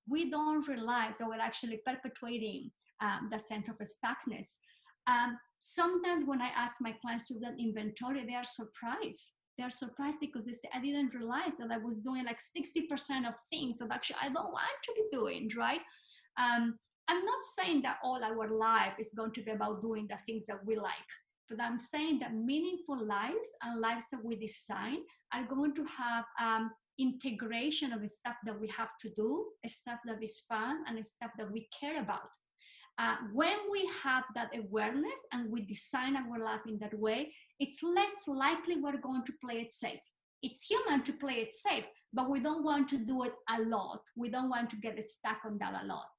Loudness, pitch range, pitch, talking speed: -37 LUFS, 225-280 Hz, 240 Hz, 205 wpm